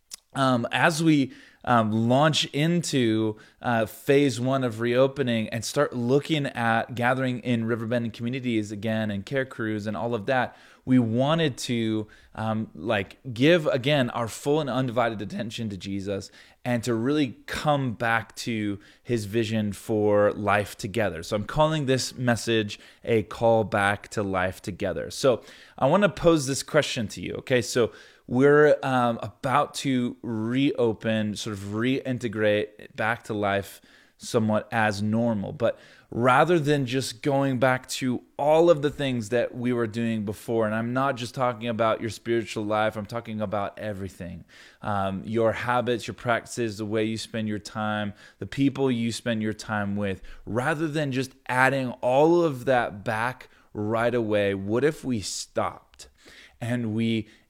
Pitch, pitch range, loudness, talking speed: 120 Hz, 110-130 Hz, -25 LUFS, 160 wpm